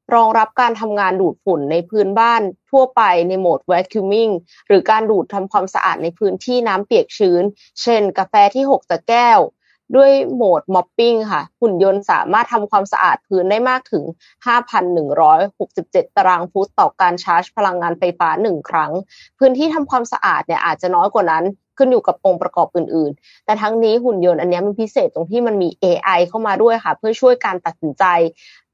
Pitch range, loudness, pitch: 180-230 Hz, -15 LUFS, 200 Hz